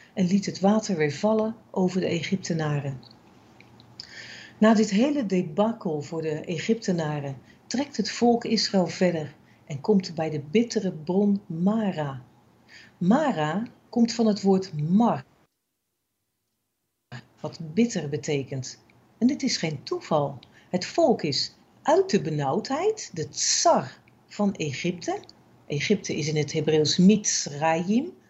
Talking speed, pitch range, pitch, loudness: 125 wpm, 150-215 Hz, 180 Hz, -25 LUFS